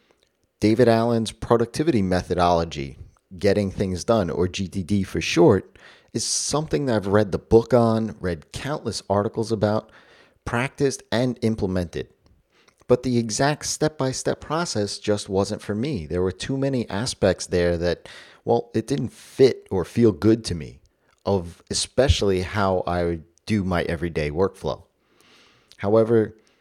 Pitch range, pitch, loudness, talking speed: 90-120 Hz, 105 Hz, -23 LUFS, 140 wpm